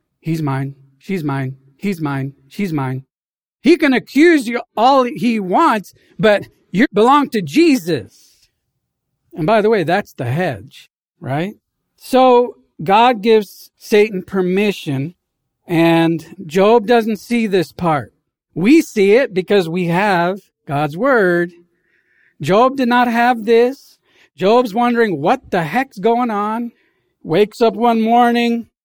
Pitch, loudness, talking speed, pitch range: 205 Hz, -15 LUFS, 130 wpm, 165-240 Hz